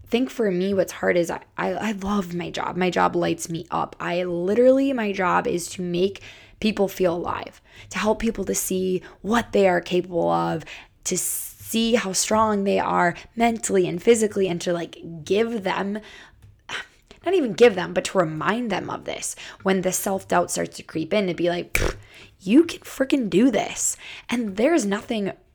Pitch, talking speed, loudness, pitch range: 195 Hz, 185 wpm, -23 LUFS, 175-225 Hz